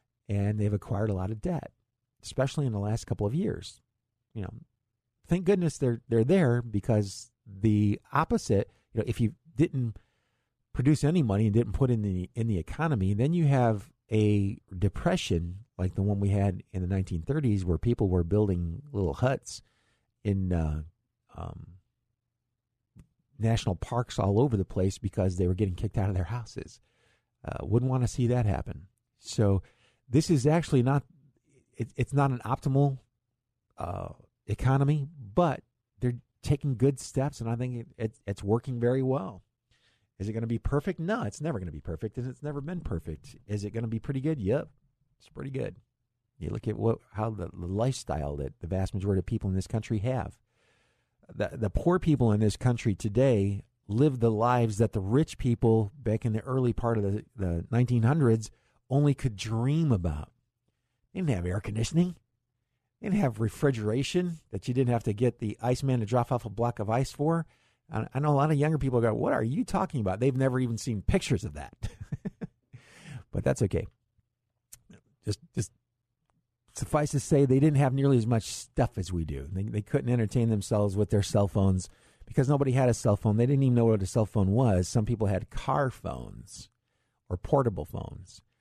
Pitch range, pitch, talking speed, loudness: 105-130 Hz, 115 Hz, 190 wpm, -29 LUFS